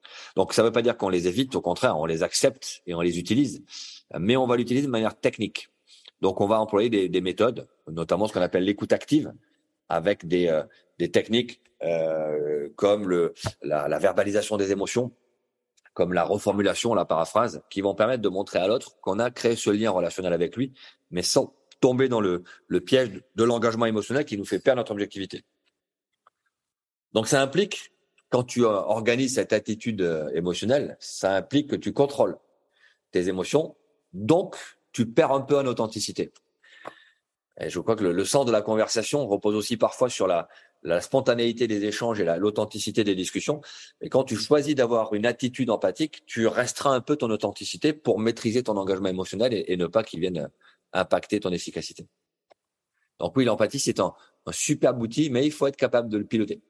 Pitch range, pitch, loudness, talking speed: 100-125 Hz, 110 Hz, -25 LUFS, 190 wpm